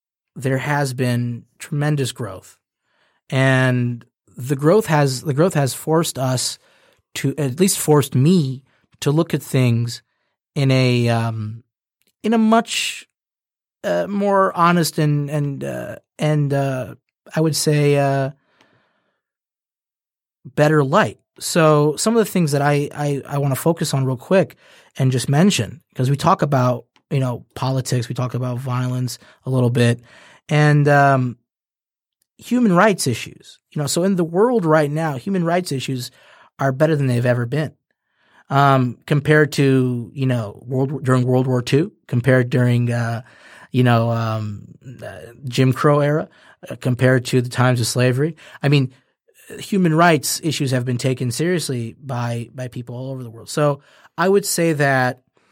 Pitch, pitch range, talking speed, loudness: 135 Hz, 125-155 Hz, 155 wpm, -19 LUFS